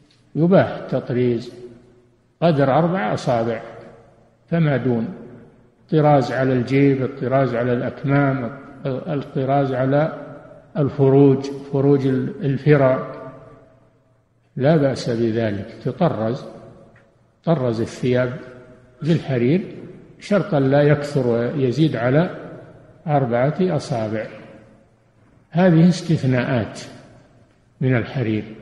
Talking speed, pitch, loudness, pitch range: 75 wpm, 130 Hz, -19 LUFS, 120-145 Hz